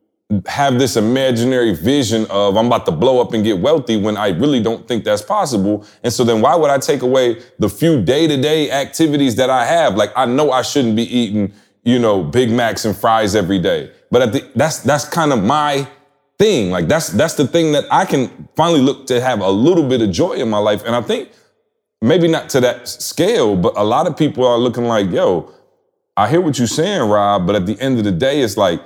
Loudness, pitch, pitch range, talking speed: -15 LUFS, 125 Hz, 110-145 Hz, 230 wpm